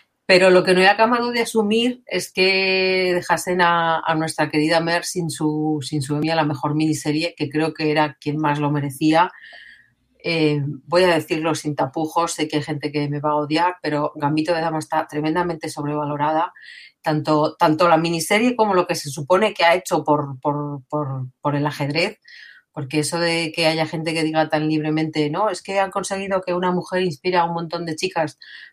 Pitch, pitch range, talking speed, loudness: 160 Hz, 150-175 Hz, 200 wpm, -20 LUFS